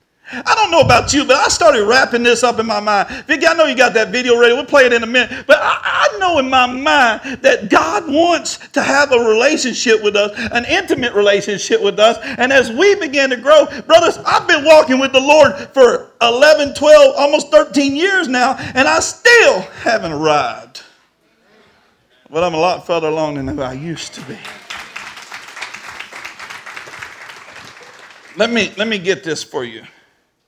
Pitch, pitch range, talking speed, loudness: 260 Hz, 225-310 Hz, 185 wpm, -12 LUFS